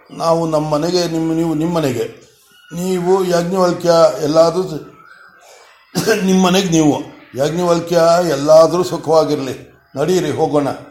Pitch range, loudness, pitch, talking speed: 155-180 Hz, -15 LUFS, 165 Hz, 90 wpm